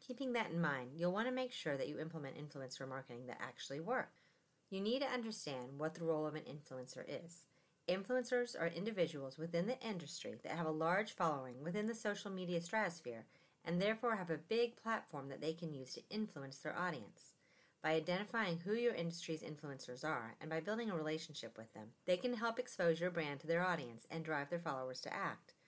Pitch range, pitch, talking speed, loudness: 145-210 Hz, 165 Hz, 205 wpm, -42 LUFS